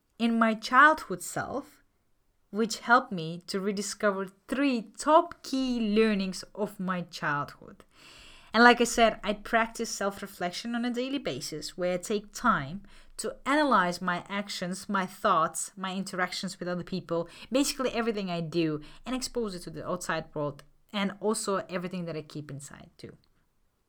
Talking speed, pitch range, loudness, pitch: 155 wpm, 175-230 Hz, -29 LUFS, 195 Hz